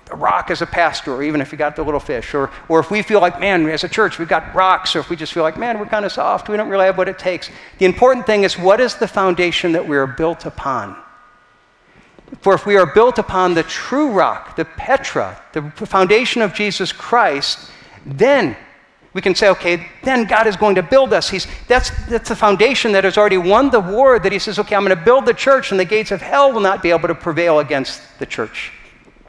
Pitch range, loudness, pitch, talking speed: 170-215 Hz, -15 LUFS, 190 Hz, 245 wpm